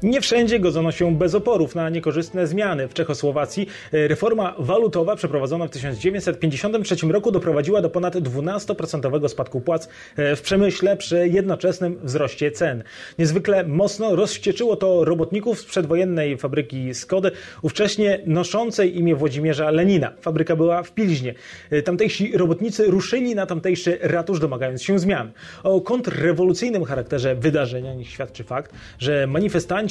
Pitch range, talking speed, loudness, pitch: 150-195 Hz, 130 wpm, -21 LUFS, 170 Hz